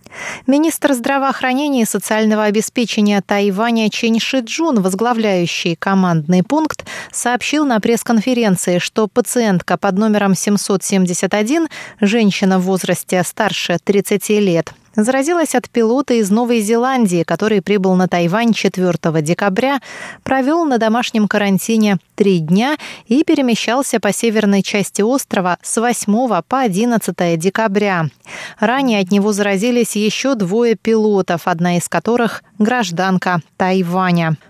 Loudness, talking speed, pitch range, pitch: -15 LUFS, 115 wpm, 190-240 Hz, 215 Hz